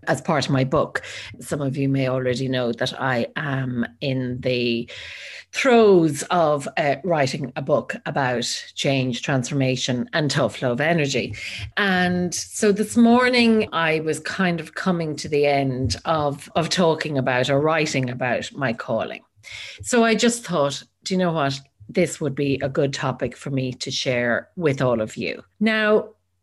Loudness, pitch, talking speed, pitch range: -22 LUFS, 140 Hz, 170 wpm, 130-170 Hz